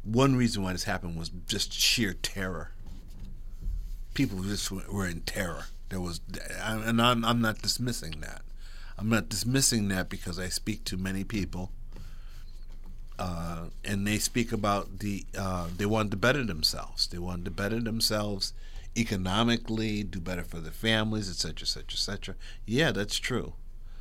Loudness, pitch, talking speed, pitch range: -30 LUFS, 100 Hz, 160 wpm, 90-110 Hz